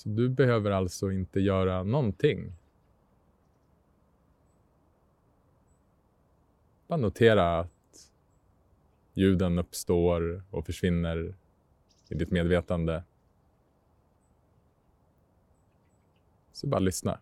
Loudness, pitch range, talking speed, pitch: -28 LUFS, 85-100 Hz, 70 wpm, 90 Hz